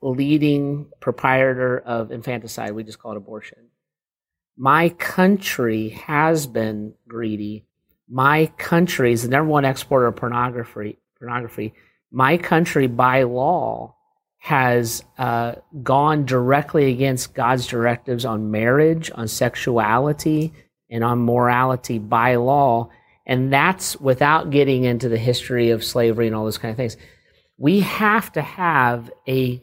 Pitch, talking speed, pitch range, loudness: 125 Hz, 130 wpm, 115-145 Hz, -19 LUFS